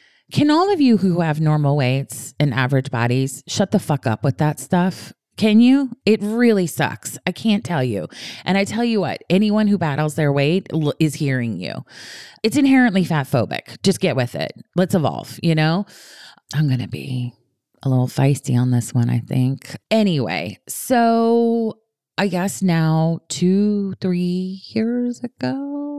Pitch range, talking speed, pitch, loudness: 135-210 Hz, 170 wpm, 165 Hz, -19 LUFS